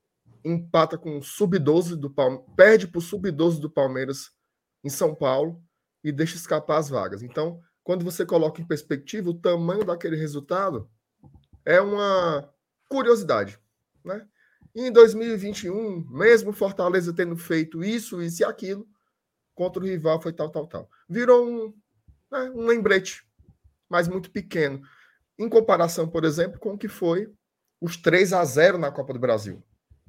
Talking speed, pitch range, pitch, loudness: 155 wpm, 155-200 Hz, 170 Hz, -23 LUFS